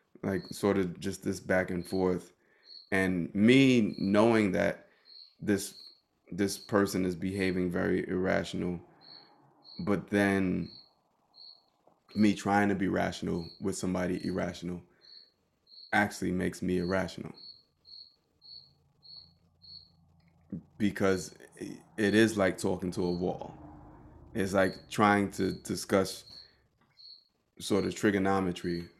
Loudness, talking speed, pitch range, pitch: -30 LUFS, 100 wpm, 90-100 Hz, 95 Hz